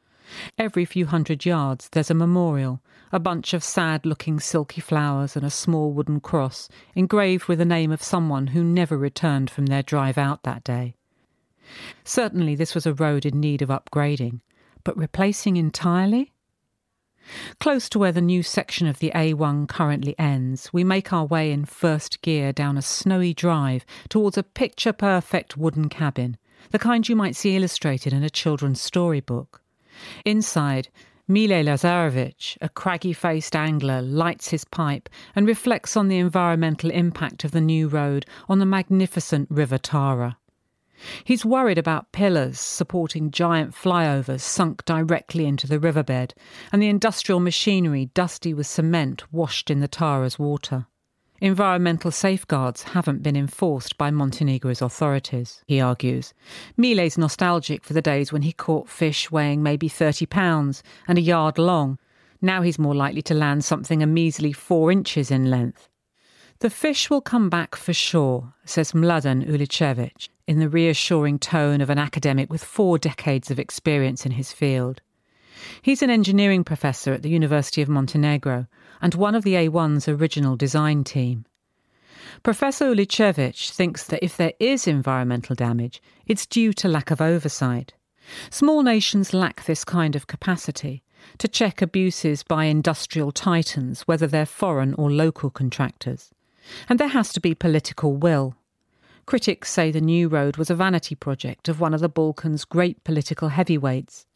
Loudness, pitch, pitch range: -22 LUFS, 160 Hz, 140-180 Hz